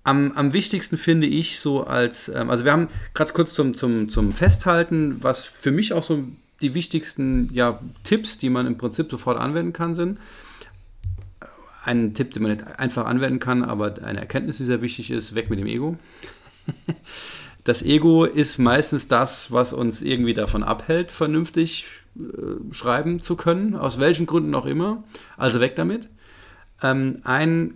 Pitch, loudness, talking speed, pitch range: 135 Hz, -22 LUFS, 165 wpm, 120-165 Hz